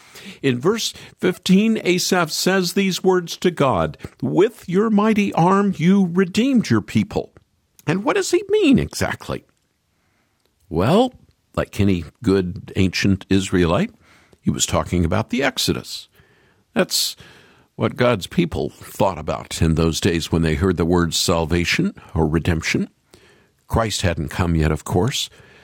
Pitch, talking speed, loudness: 110 Hz, 135 wpm, -19 LUFS